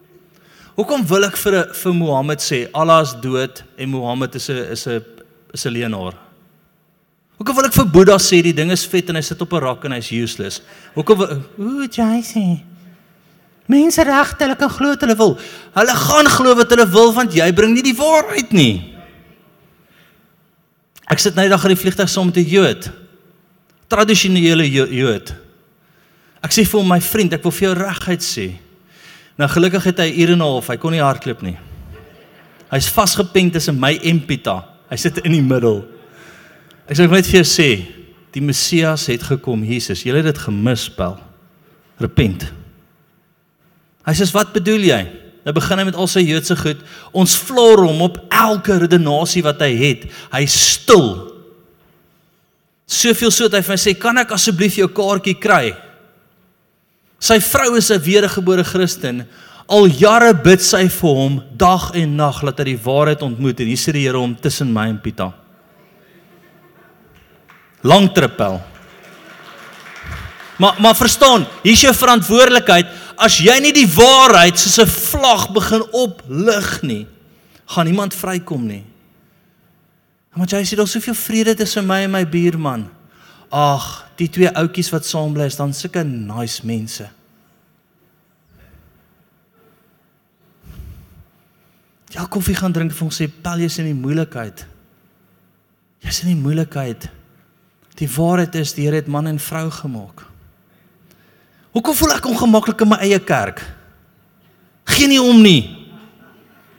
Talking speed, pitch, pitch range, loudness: 155 wpm, 175 Hz, 140-200 Hz, -14 LUFS